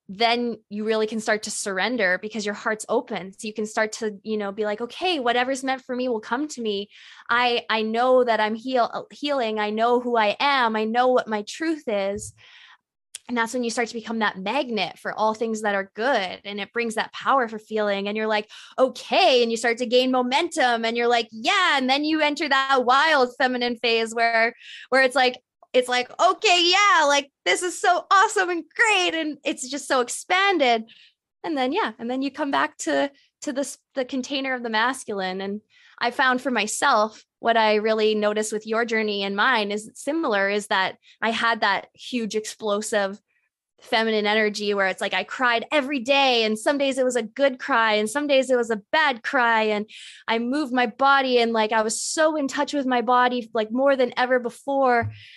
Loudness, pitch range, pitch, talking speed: -22 LUFS, 215-275 Hz, 240 Hz, 210 wpm